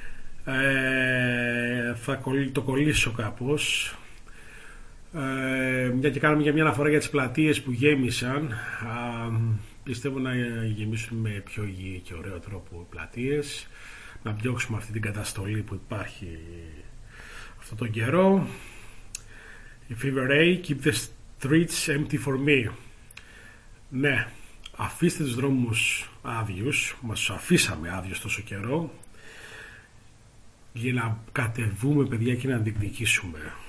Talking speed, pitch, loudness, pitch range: 115 wpm, 120 Hz, -26 LUFS, 110-135 Hz